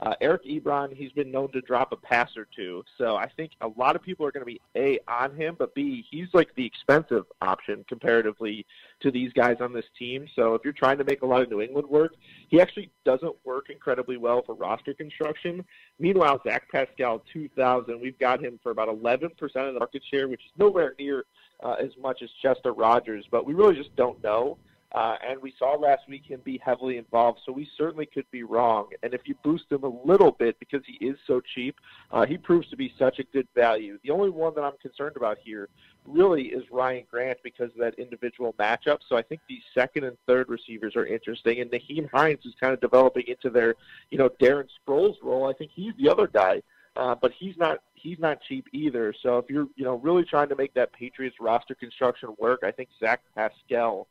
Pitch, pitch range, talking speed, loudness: 135 Hz, 120-155 Hz, 225 wpm, -26 LUFS